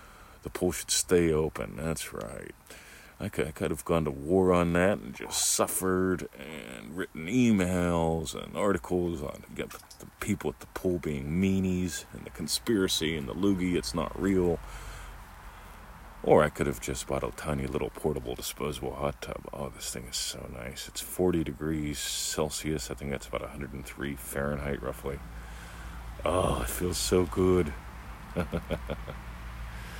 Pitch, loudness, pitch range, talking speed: 80 Hz, -30 LUFS, 70-90 Hz, 160 wpm